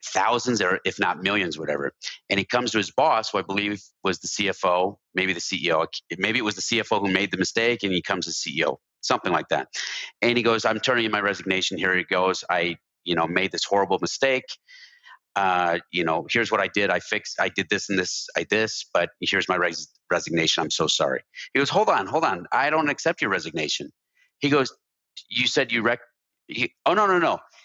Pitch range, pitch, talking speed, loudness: 95-120 Hz, 100 Hz, 220 wpm, -23 LUFS